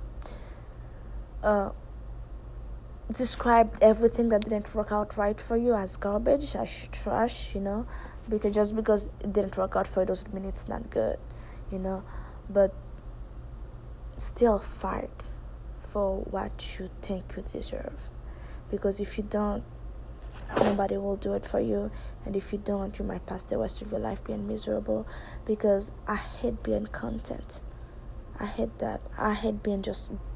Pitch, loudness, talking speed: 195 Hz, -29 LUFS, 150 wpm